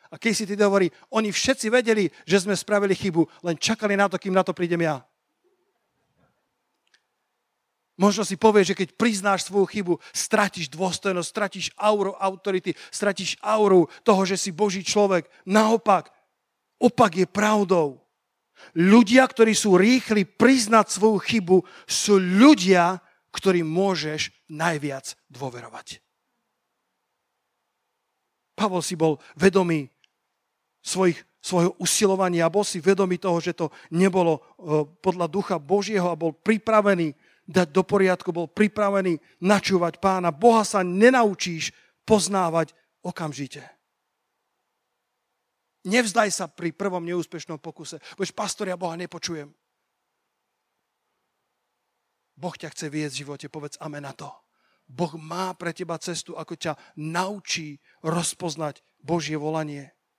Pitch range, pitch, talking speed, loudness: 165-205 Hz, 185 Hz, 120 wpm, -22 LUFS